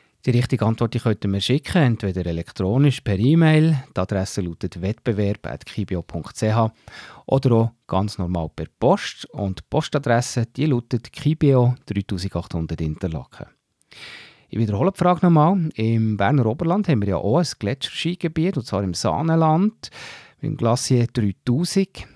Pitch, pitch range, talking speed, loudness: 115 Hz, 100-145 Hz, 135 wpm, -21 LUFS